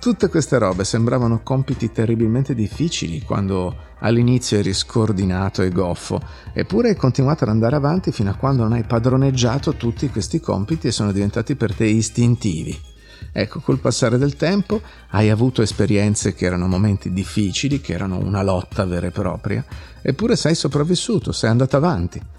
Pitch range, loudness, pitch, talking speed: 100-135 Hz, -19 LUFS, 115 Hz, 160 wpm